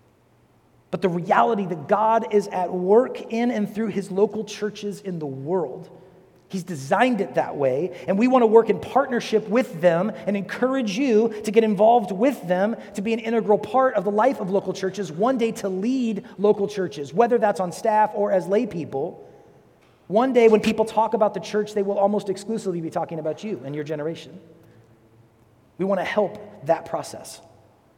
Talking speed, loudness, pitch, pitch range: 190 wpm, -22 LUFS, 205 Hz, 180-220 Hz